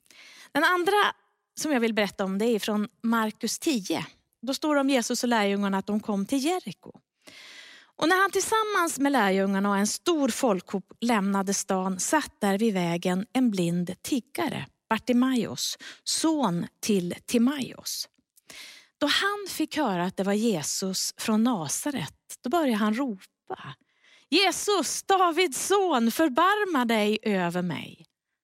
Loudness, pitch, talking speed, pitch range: -26 LUFS, 235 Hz, 145 wpm, 200-310 Hz